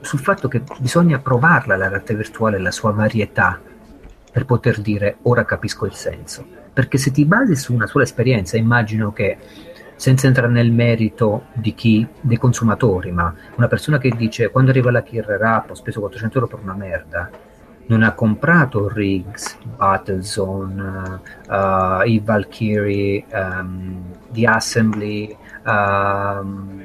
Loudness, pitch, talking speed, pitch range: -18 LUFS, 110 Hz, 145 wpm, 100-120 Hz